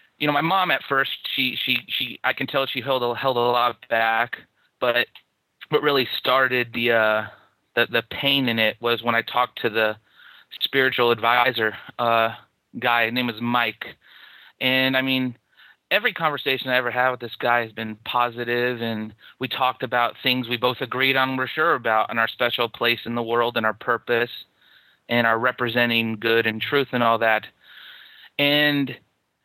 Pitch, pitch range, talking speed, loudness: 120 Hz, 115-130 Hz, 185 wpm, -22 LUFS